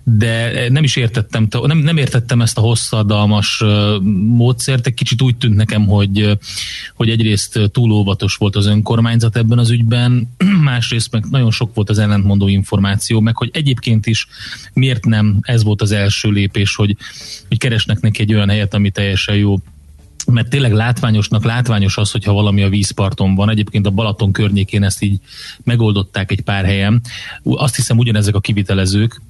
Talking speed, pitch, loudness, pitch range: 160 wpm, 110 Hz, -14 LUFS, 100-120 Hz